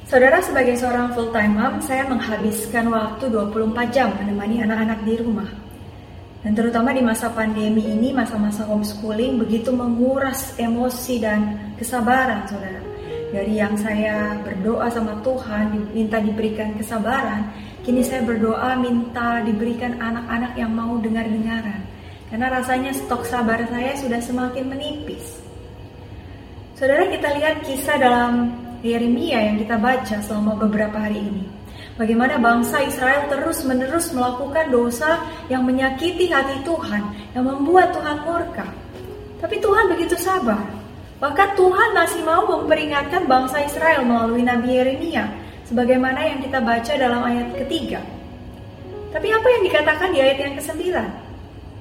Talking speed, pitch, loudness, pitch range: 130 wpm, 245 Hz, -20 LUFS, 220-275 Hz